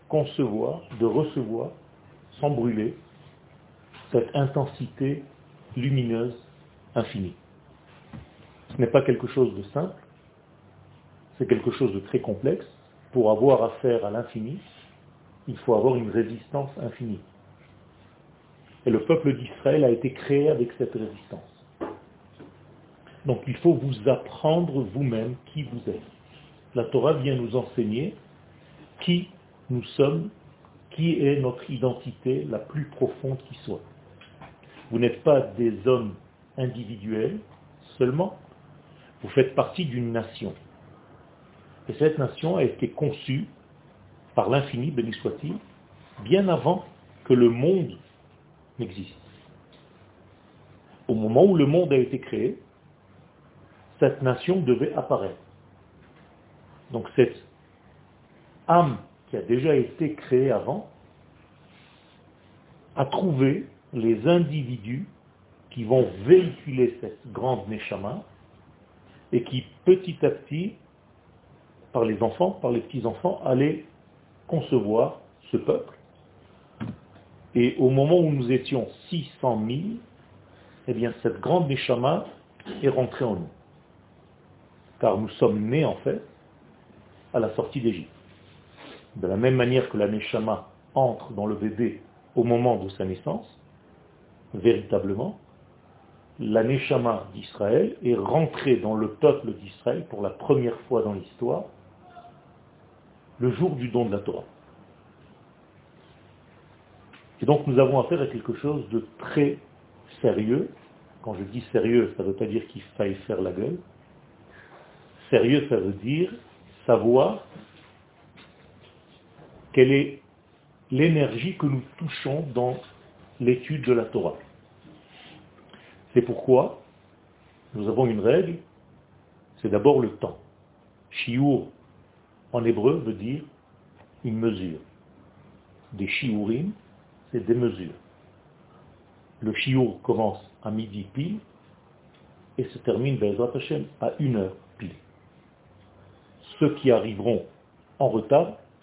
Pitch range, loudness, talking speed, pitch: 115-145 Hz, -25 LUFS, 120 wpm, 125 Hz